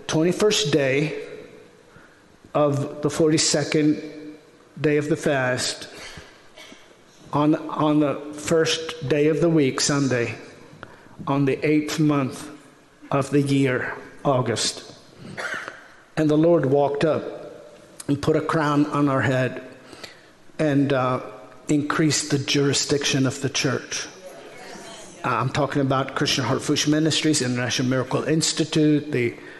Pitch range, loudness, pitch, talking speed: 140-155 Hz, -22 LUFS, 145 Hz, 115 wpm